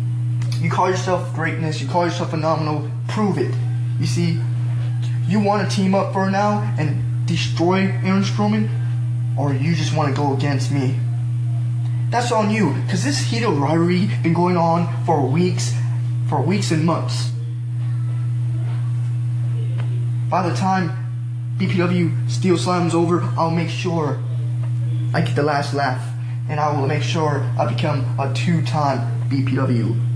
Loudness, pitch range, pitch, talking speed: -20 LUFS, 120-135 Hz, 120 Hz, 140 wpm